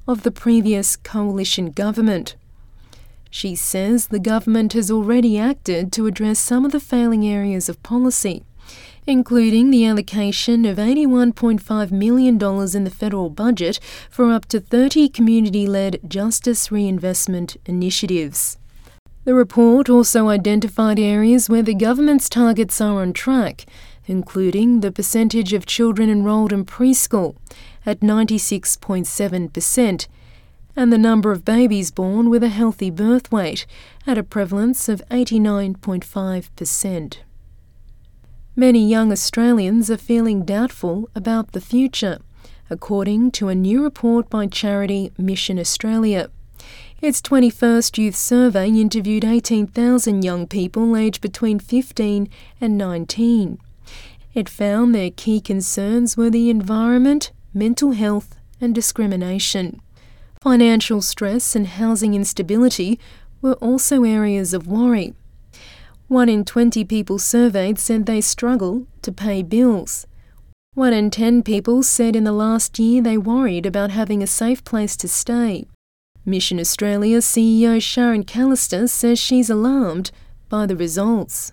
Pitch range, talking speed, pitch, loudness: 195-235 Hz, 125 wpm, 220 Hz, -17 LUFS